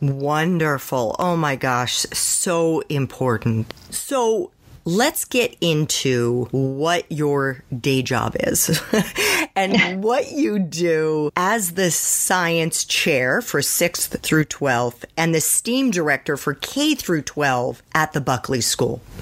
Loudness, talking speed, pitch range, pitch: -20 LUFS, 120 wpm, 135-185 Hz, 155 Hz